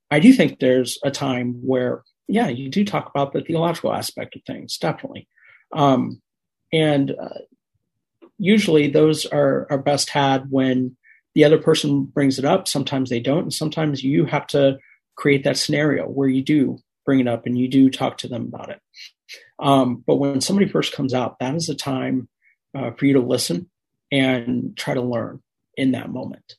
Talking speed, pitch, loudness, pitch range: 185 wpm, 140 Hz, -20 LUFS, 130-150 Hz